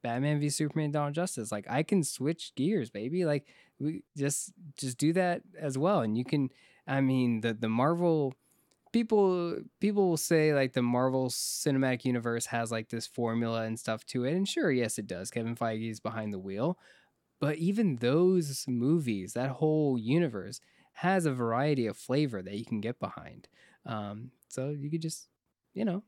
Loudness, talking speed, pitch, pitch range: -31 LUFS, 180 wpm, 135 Hz, 115-160 Hz